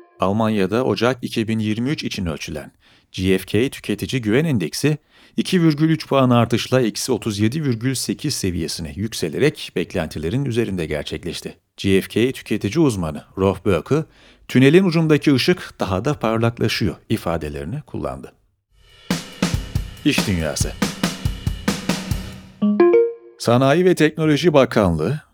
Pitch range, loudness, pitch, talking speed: 105-150 Hz, -20 LUFS, 120 Hz, 90 wpm